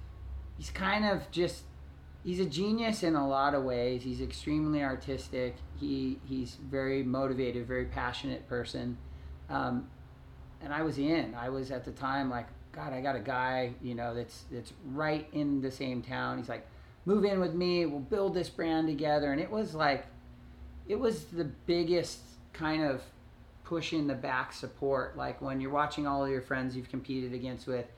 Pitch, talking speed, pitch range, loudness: 135 Hz, 180 wpm, 120-155 Hz, -34 LUFS